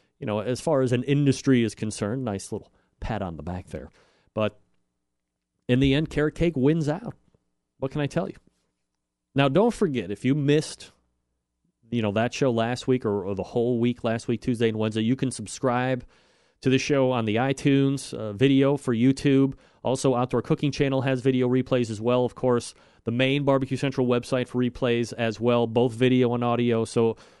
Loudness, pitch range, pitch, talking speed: -25 LUFS, 110-135 Hz, 125 Hz, 195 wpm